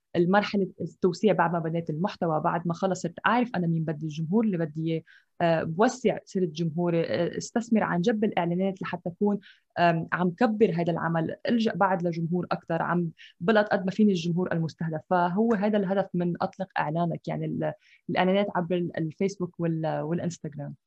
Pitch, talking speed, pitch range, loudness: 175 Hz, 150 wpm, 170-195 Hz, -27 LUFS